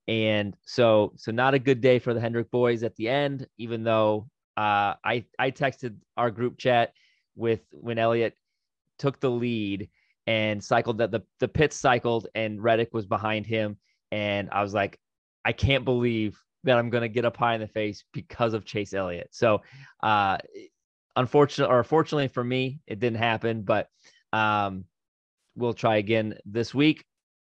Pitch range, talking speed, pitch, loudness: 110-125 Hz, 170 wpm, 115 Hz, -26 LUFS